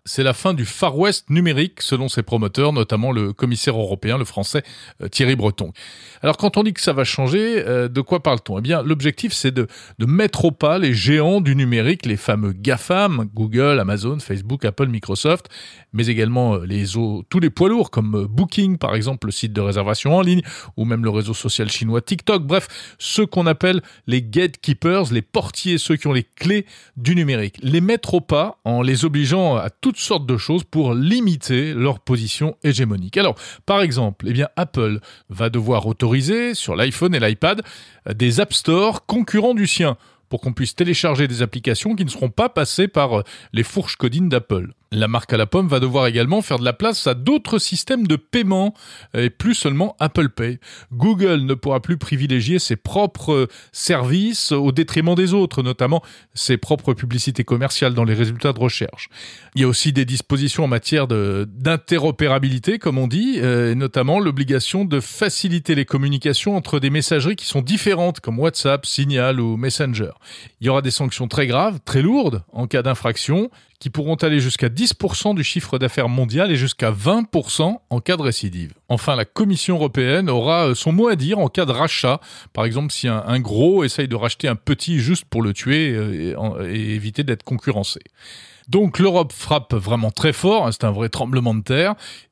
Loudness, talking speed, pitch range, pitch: -19 LUFS, 190 wpm, 120-170 Hz, 135 Hz